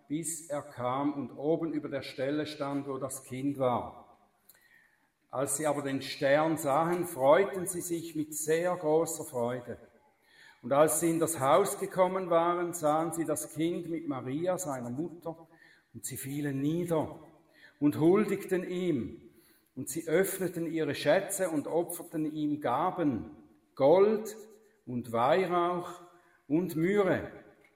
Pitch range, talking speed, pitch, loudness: 140-175 Hz, 135 wpm, 160 Hz, -31 LUFS